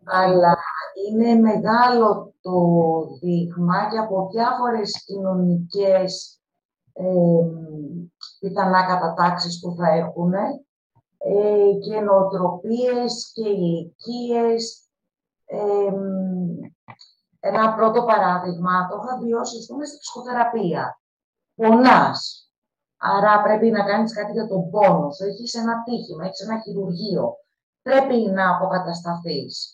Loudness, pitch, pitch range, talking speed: -20 LUFS, 200 Hz, 180-225 Hz, 100 wpm